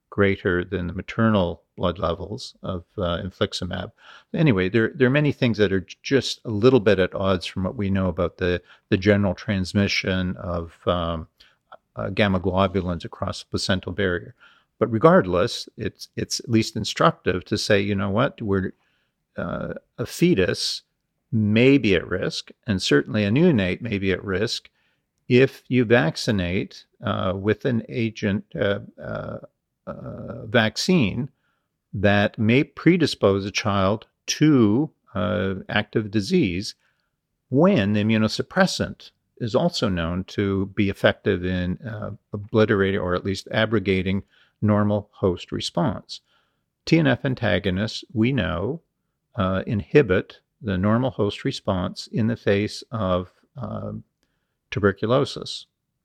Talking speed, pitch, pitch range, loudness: 135 wpm, 105 Hz, 95-115 Hz, -23 LUFS